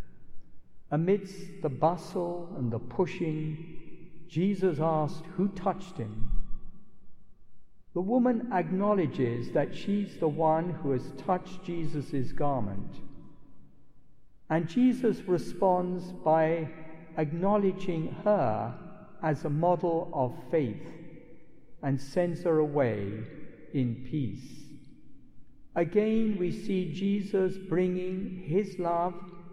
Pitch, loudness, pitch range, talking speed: 165 Hz, -30 LUFS, 150-185 Hz, 95 wpm